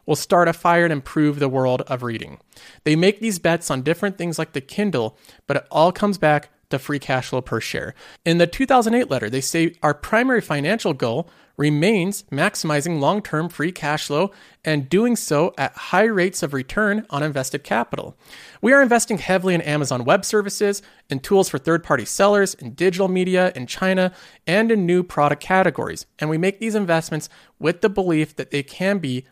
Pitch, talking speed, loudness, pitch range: 170 Hz, 190 wpm, -20 LUFS, 145-200 Hz